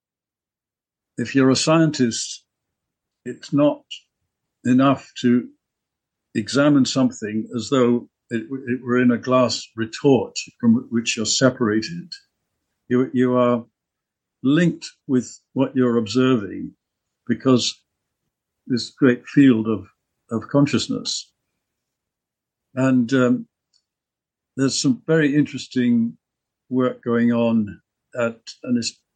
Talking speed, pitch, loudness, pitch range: 100 wpm, 125 Hz, -20 LUFS, 115-135 Hz